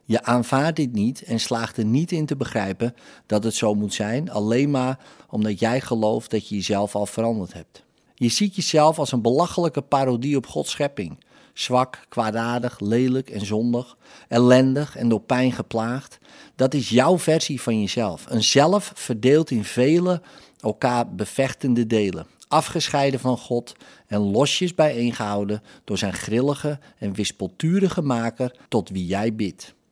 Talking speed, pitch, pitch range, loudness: 155 wpm, 120 Hz, 110-140 Hz, -22 LUFS